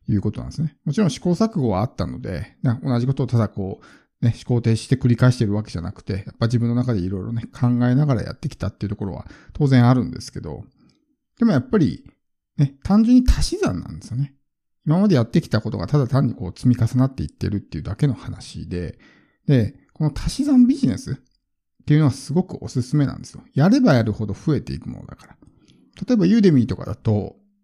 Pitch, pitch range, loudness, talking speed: 125 Hz, 110-150 Hz, -21 LUFS, 445 characters per minute